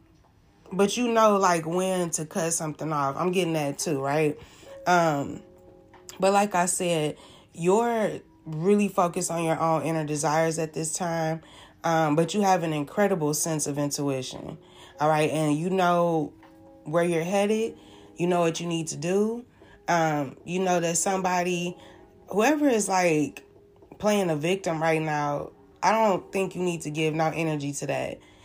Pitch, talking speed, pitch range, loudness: 165 Hz, 165 wpm, 155-185 Hz, -25 LUFS